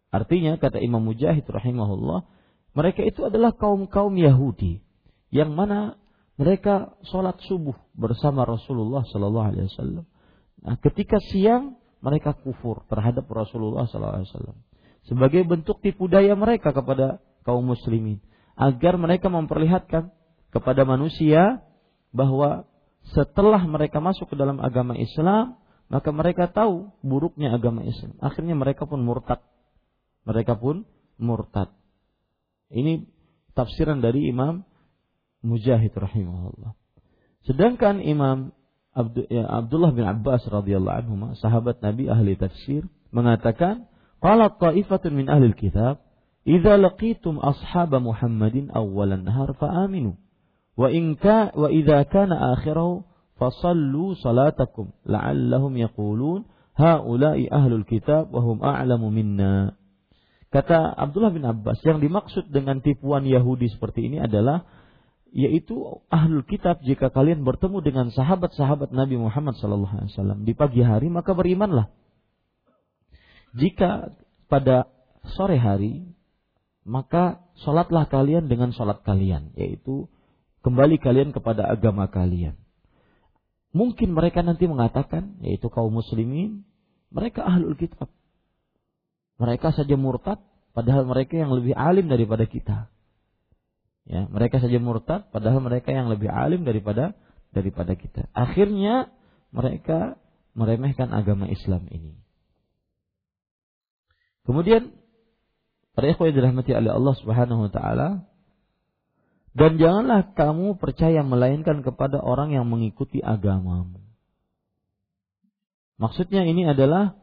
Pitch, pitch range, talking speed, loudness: 135 Hz, 115-170 Hz, 110 wpm, -22 LUFS